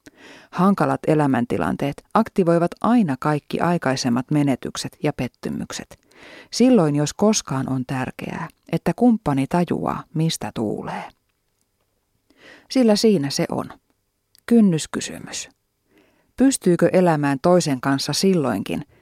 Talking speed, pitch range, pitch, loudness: 90 wpm, 135-200 Hz, 160 Hz, -20 LUFS